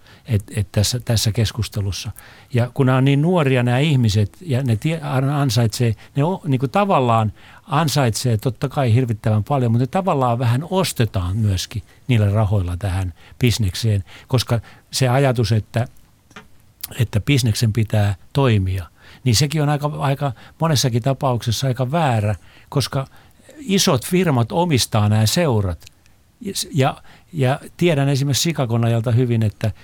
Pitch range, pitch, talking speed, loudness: 105-140 Hz, 120 Hz, 135 wpm, -19 LUFS